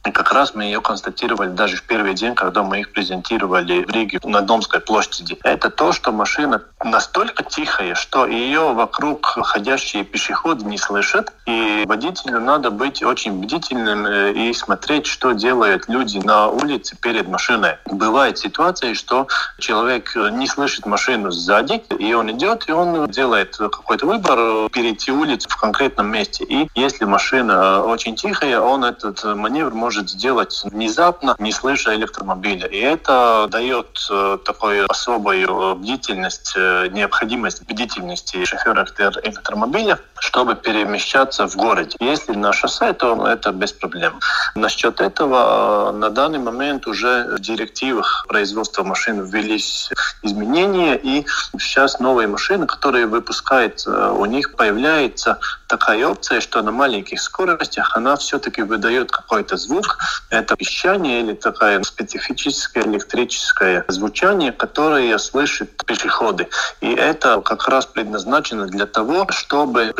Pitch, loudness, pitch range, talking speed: 115 Hz, -17 LUFS, 105-135 Hz, 130 wpm